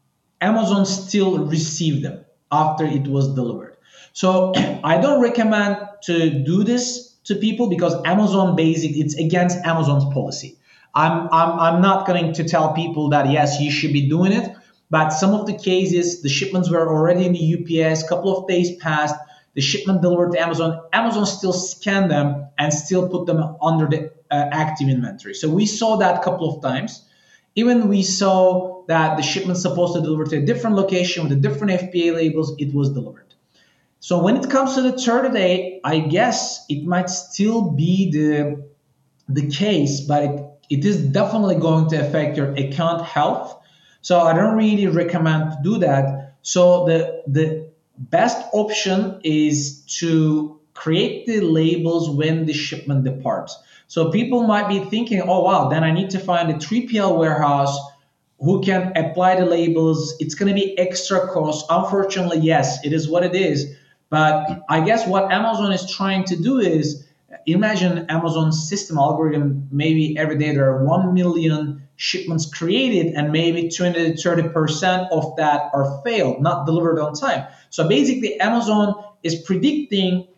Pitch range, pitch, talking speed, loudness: 155-190 Hz, 165 Hz, 170 wpm, -19 LUFS